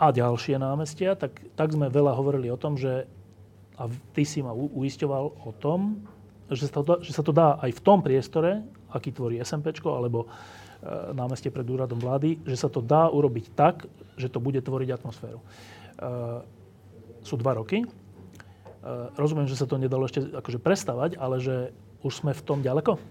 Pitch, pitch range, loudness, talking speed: 130 Hz, 115-150 Hz, -27 LUFS, 180 wpm